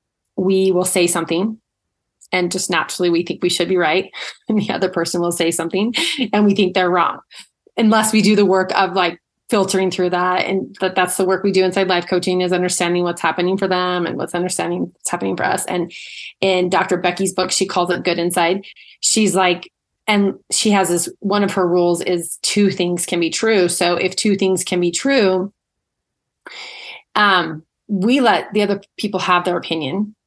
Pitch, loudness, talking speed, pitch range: 185 Hz, -17 LUFS, 200 wpm, 175-195 Hz